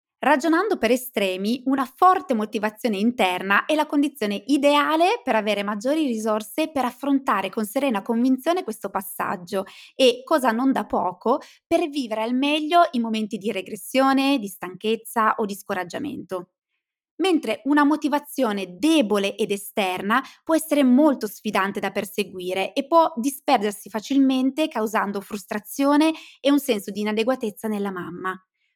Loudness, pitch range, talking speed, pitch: -22 LUFS, 210-285 Hz, 135 wpm, 235 Hz